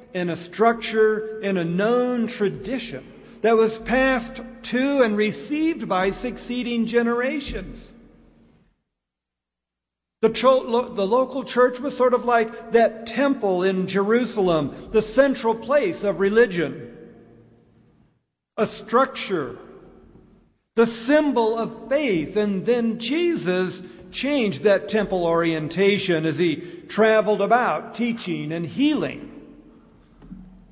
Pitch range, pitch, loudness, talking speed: 190-245 Hz, 225 Hz, -22 LUFS, 105 wpm